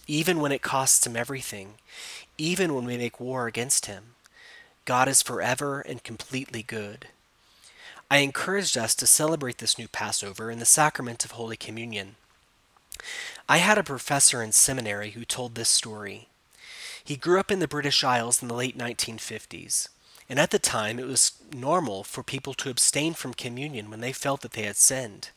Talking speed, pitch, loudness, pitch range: 175 wpm, 125 Hz, -24 LUFS, 115-140 Hz